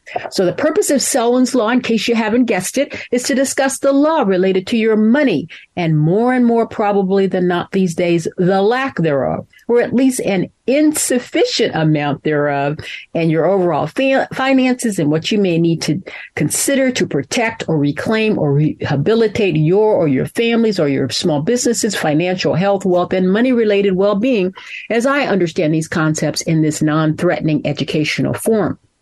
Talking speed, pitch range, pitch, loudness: 170 wpm, 160-240 Hz, 195 Hz, -15 LUFS